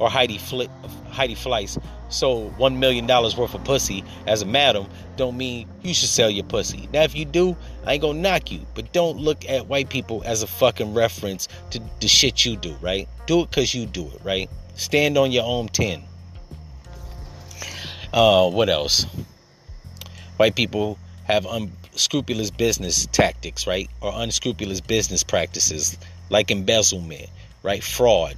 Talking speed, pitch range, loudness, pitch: 165 wpm, 90-125 Hz, -21 LUFS, 105 Hz